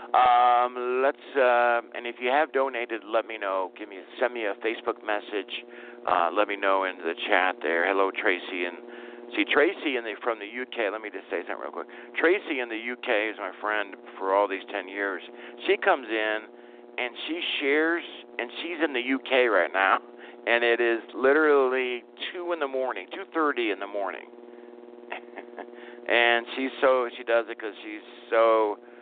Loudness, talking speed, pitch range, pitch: -26 LUFS, 185 wpm, 110-125 Hz, 120 Hz